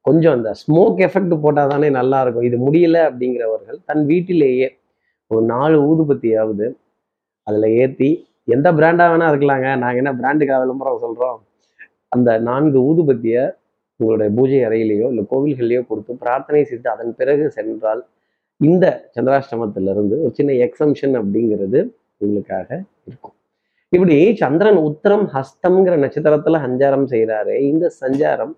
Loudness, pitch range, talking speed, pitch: -16 LUFS, 115-155 Hz, 120 wpm, 135 Hz